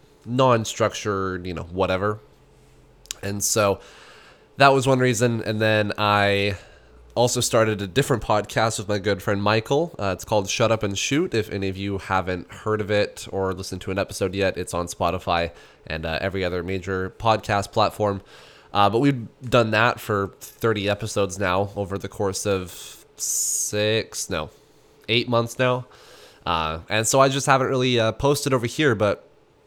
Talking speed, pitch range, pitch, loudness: 170 wpm, 95-115 Hz, 105 Hz, -23 LUFS